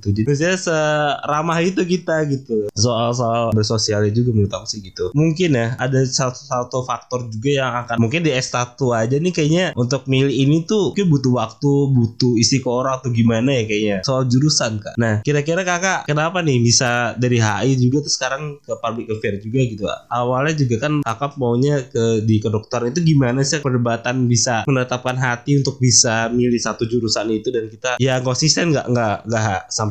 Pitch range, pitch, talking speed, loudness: 115-140 Hz, 125 Hz, 180 wpm, -18 LUFS